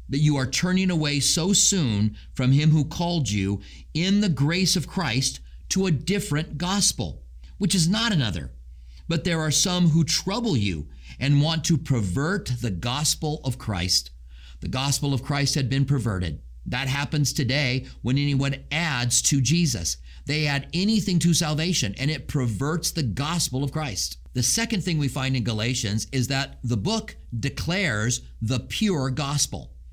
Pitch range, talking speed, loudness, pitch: 115-165 Hz, 165 wpm, -24 LUFS, 140 Hz